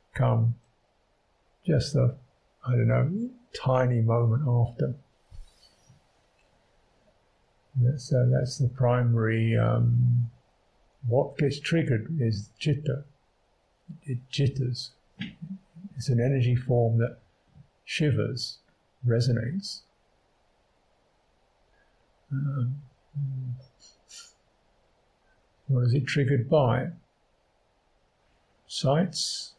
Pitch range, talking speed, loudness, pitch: 120-140 Hz, 75 wpm, -27 LUFS, 125 Hz